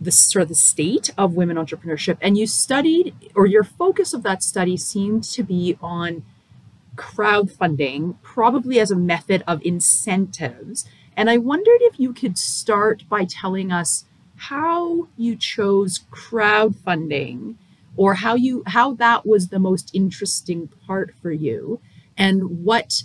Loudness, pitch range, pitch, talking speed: -19 LUFS, 175-230 Hz, 195 Hz, 145 wpm